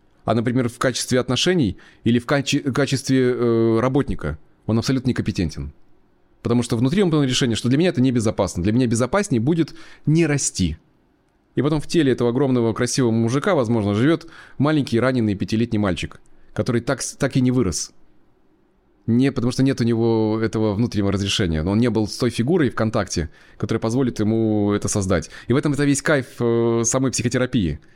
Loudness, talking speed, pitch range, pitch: -20 LUFS, 180 wpm, 110-135 Hz, 120 Hz